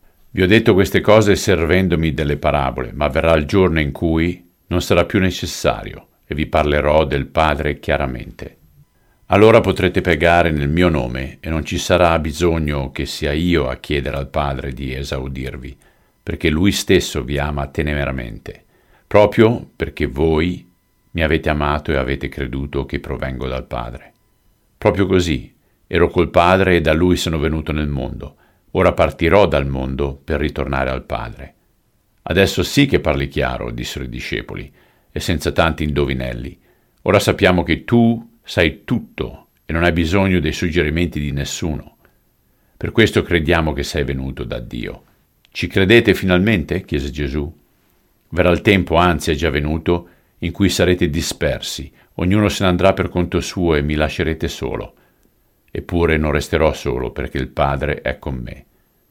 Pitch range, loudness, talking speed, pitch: 70-90 Hz, -17 LUFS, 155 wpm, 80 Hz